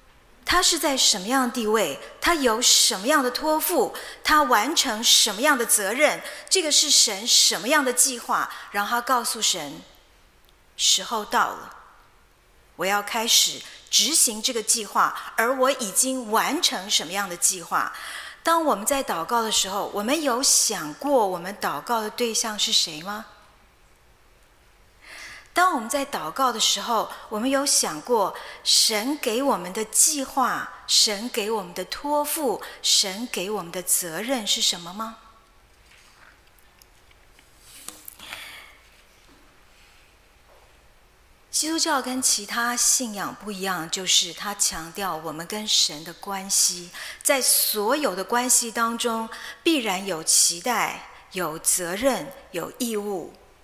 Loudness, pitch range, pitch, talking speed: -21 LUFS, 205-275 Hz, 230 Hz, 190 characters per minute